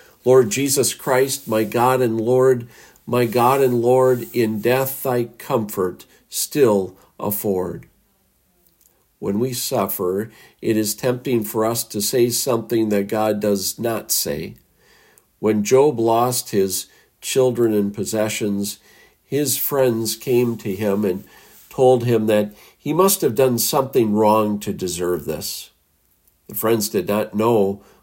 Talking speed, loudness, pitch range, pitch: 135 wpm, -19 LUFS, 105-125 Hz, 115 Hz